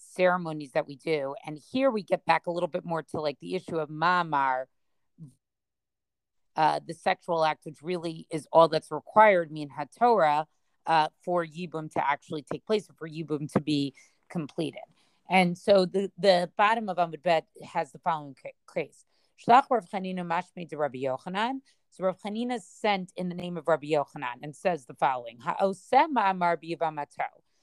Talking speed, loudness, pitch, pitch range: 165 wpm, -28 LUFS, 165 Hz, 150-185 Hz